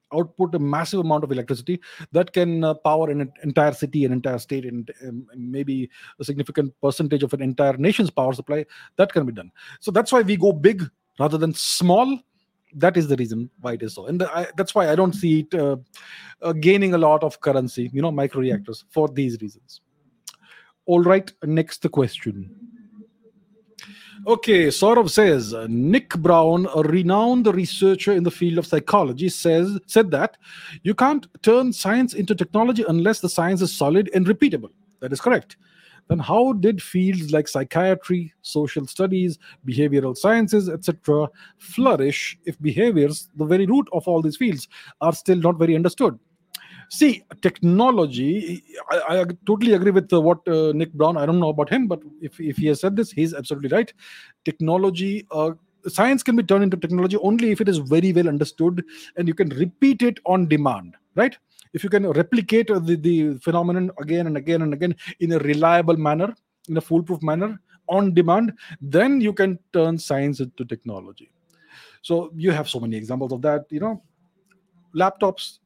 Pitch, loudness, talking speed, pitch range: 170 Hz, -20 LUFS, 175 wpm, 150-195 Hz